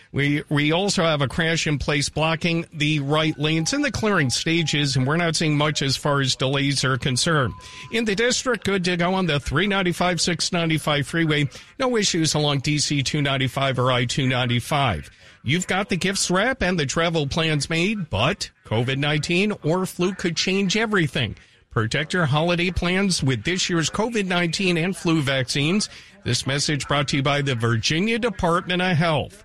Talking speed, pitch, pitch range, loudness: 175 wpm, 160 Hz, 140-180 Hz, -21 LUFS